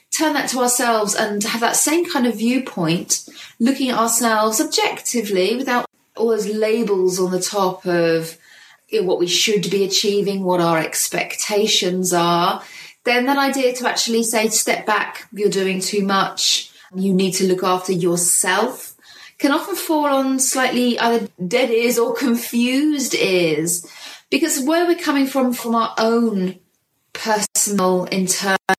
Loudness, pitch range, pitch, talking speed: -18 LUFS, 190-255 Hz, 220 Hz, 150 wpm